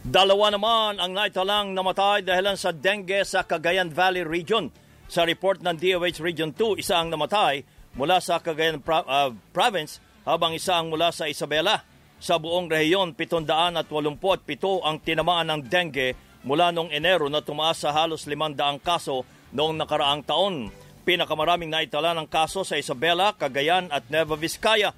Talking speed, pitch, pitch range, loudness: 150 wpm, 170 Hz, 155-185 Hz, -24 LUFS